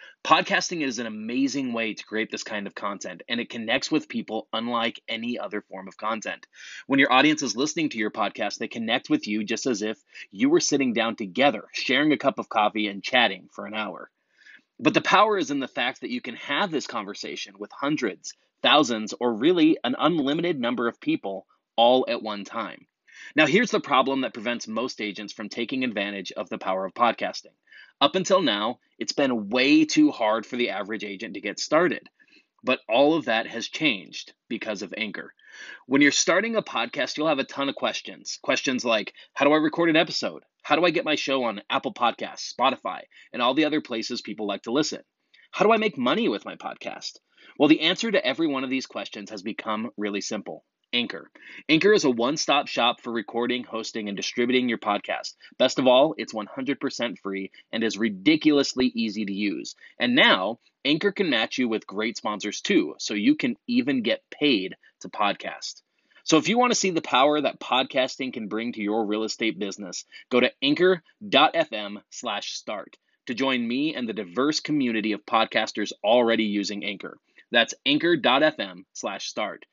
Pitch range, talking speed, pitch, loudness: 110-180 Hz, 195 wpm, 125 Hz, -24 LUFS